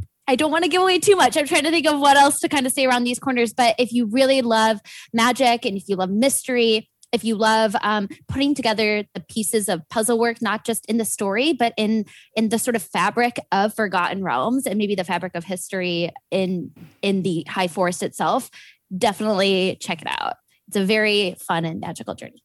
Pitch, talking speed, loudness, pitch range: 220 Hz, 220 wpm, -20 LUFS, 195-245 Hz